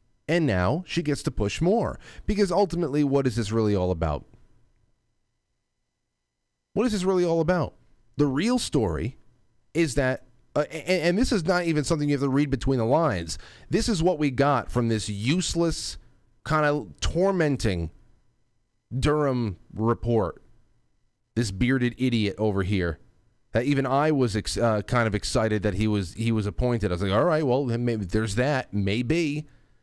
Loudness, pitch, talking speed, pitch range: -25 LUFS, 120 Hz, 170 wpm, 110-150 Hz